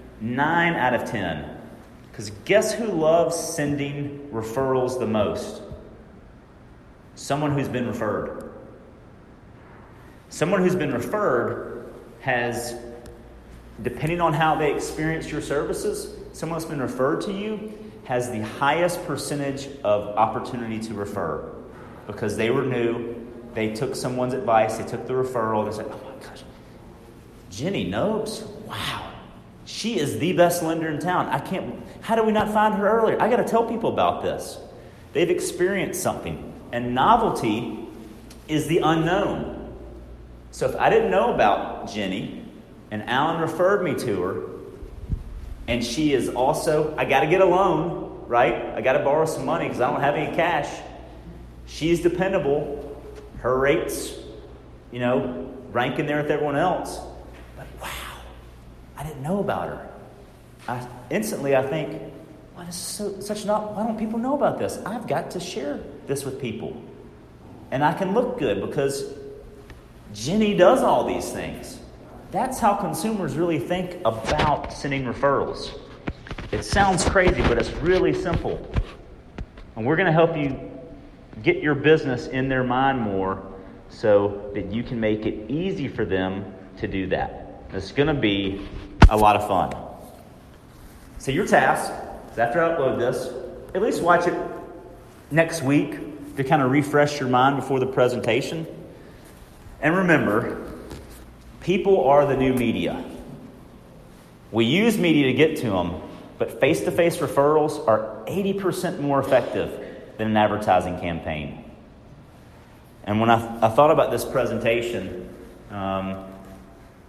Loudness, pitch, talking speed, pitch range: -23 LUFS, 130 Hz, 145 wpm, 110-165 Hz